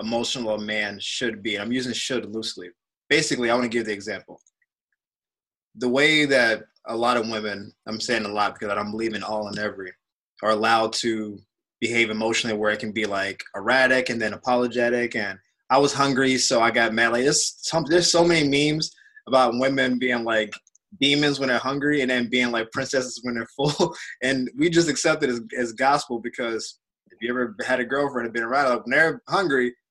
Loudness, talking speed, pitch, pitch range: -22 LUFS, 200 wpm, 120 Hz, 110-135 Hz